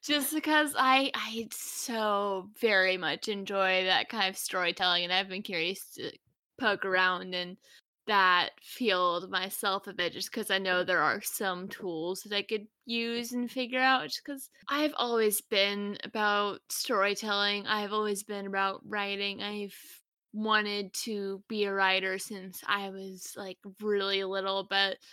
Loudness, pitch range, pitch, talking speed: -30 LUFS, 190-220 Hz, 200 Hz, 155 wpm